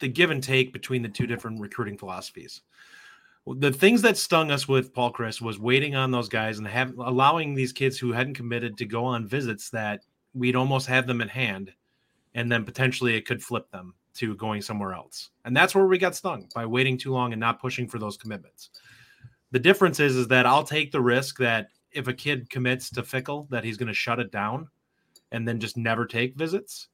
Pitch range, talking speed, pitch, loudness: 115-130 Hz, 220 wpm, 125 Hz, -25 LUFS